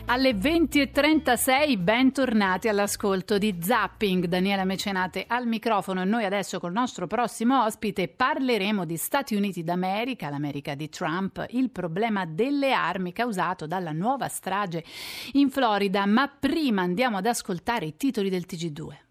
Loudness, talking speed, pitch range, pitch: -25 LUFS, 140 wpm, 185-245 Hz, 205 Hz